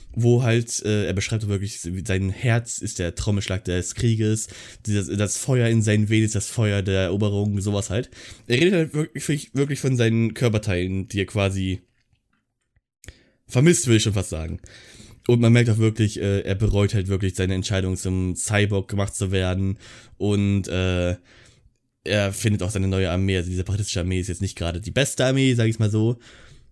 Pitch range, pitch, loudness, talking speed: 95-115 Hz, 105 Hz, -22 LUFS, 185 wpm